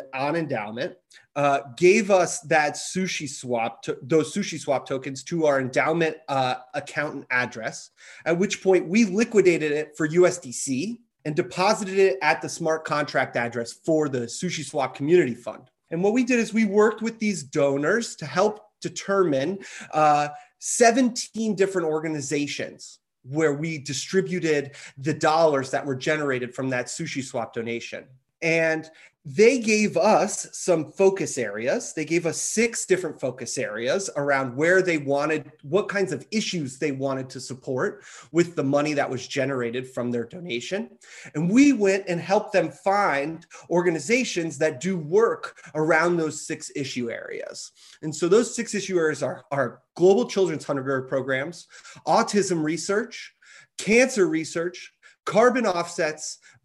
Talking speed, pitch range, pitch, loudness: 145 wpm, 140-190 Hz, 160 Hz, -24 LUFS